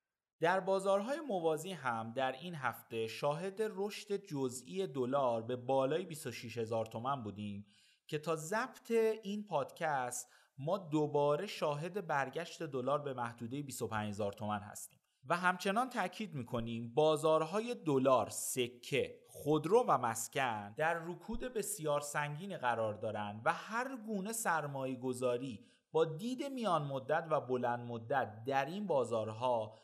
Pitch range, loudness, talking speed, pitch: 125-195 Hz, -37 LUFS, 130 wpm, 150 Hz